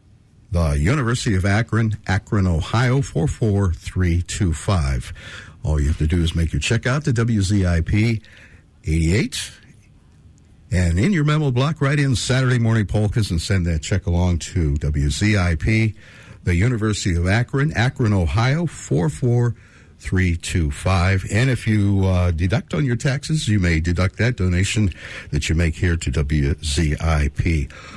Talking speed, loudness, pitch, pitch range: 155 wpm, -20 LUFS, 100 Hz, 85-115 Hz